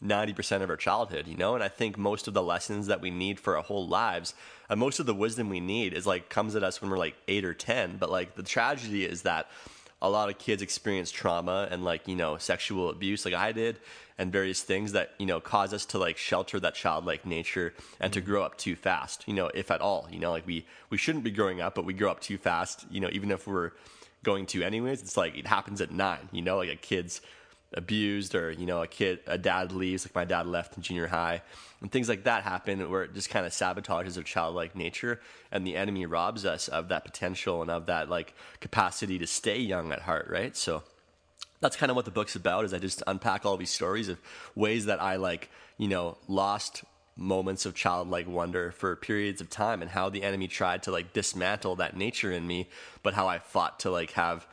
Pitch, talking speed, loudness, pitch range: 95 Hz, 240 wpm, -31 LUFS, 90-105 Hz